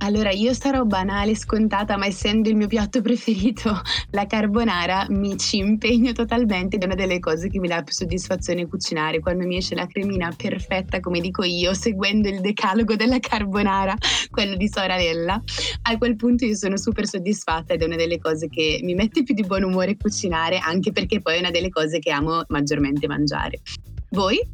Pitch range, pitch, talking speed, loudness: 175-220 Hz, 195 Hz, 190 wpm, -22 LUFS